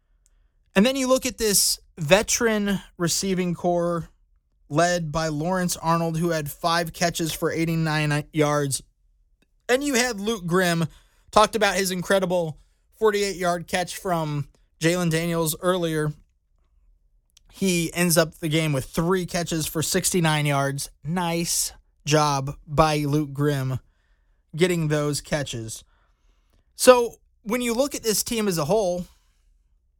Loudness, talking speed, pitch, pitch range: -23 LUFS, 130 wpm, 165 Hz, 140-185 Hz